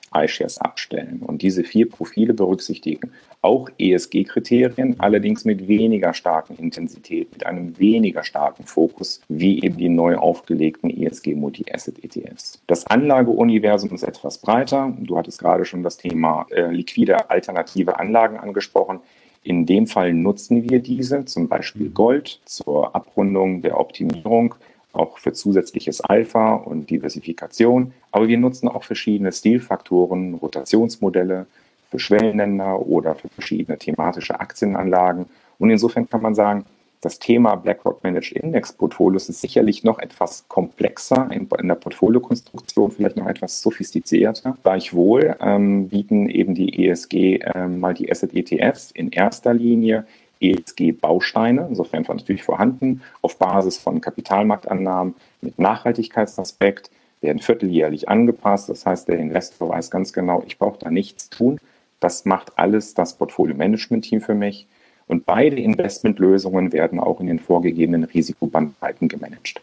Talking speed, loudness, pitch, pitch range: 135 wpm, -19 LUFS, 100 Hz, 90-115 Hz